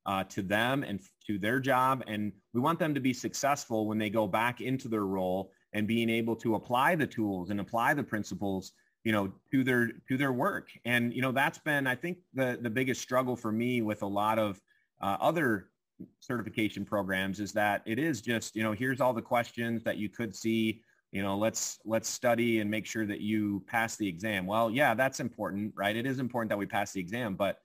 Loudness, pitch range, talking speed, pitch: -31 LUFS, 105-125 Hz, 225 wpm, 110 Hz